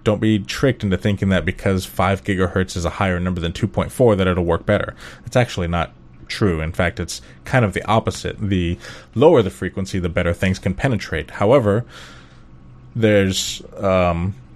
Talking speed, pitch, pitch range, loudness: 175 wpm, 95 Hz, 85-105 Hz, -19 LUFS